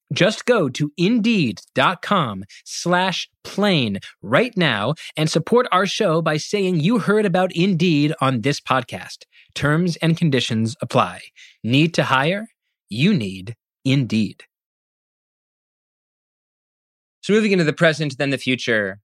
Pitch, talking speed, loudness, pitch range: 160 Hz, 125 wpm, -19 LUFS, 130-190 Hz